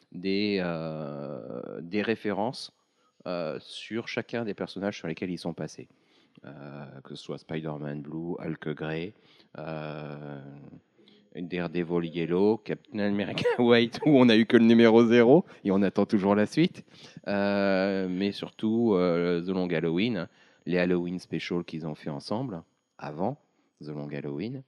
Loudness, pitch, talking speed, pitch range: -27 LUFS, 90 Hz, 145 wpm, 80-105 Hz